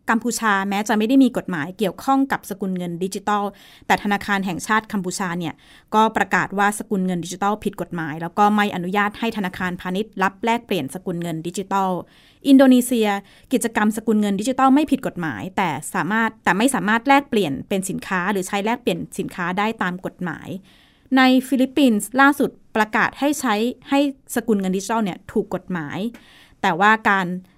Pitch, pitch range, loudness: 205 Hz, 185-230 Hz, -20 LUFS